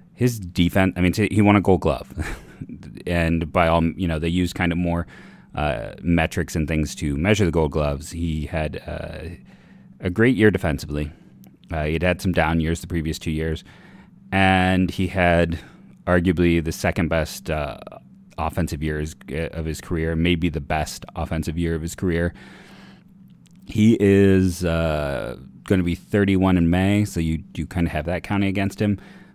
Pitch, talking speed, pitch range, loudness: 85 Hz, 175 wpm, 80-95 Hz, -22 LUFS